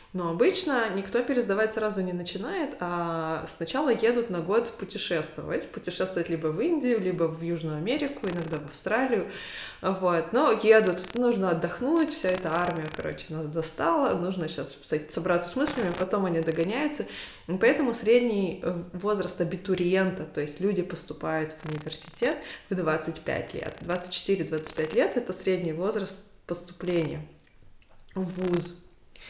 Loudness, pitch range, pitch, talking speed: -28 LUFS, 165-205 Hz, 180 Hz, 135 wpm